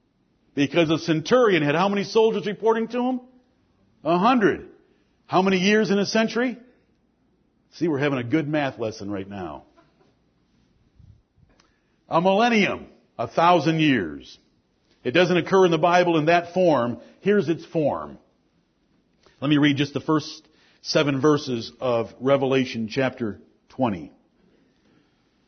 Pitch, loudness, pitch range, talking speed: 165 Hz, -22 LUFS, 140-200 Hz, 130 wpm